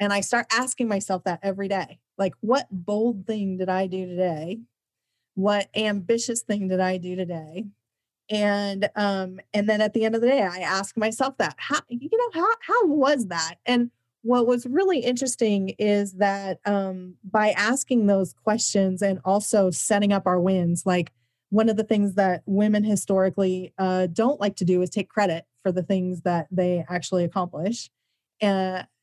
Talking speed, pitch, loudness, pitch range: 180 wpm, 200 Hz, -24 LUFS, 185-220 Hz